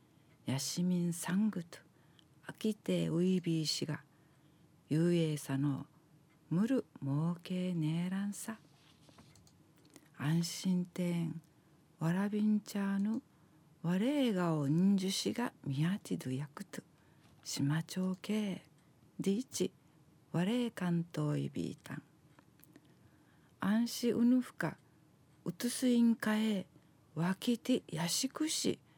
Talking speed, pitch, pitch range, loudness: 220 characters per minute, 170 Hz, 155-205 Hz, -35 LUFS